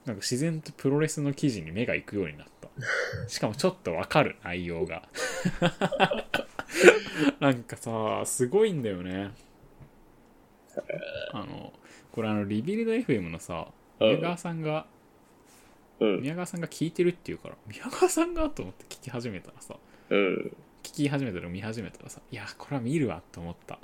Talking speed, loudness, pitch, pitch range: 310 characters per minute, -29 LUFS, 145 Hz, 105-175 Hz